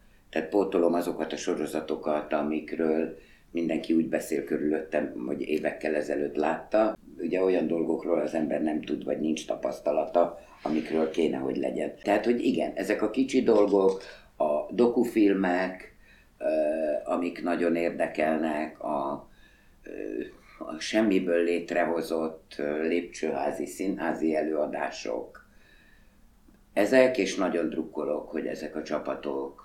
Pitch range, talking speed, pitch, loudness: 80-95 Hz, 110 wpm, 85 Hz, -28 LUFS